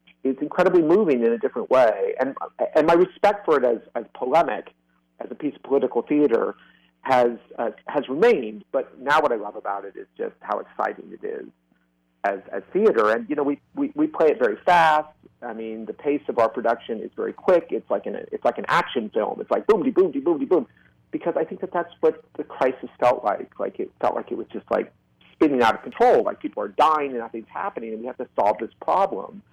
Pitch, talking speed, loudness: 150 Hz, 235 wpm, -23 LUFS